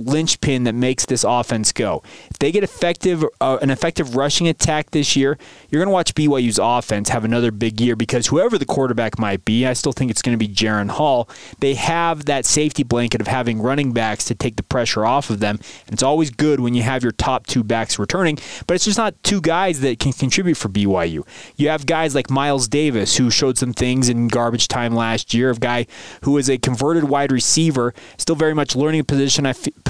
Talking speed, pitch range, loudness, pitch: 225 wpm, 120-150 Hz, -18 LUFS, 130 Hz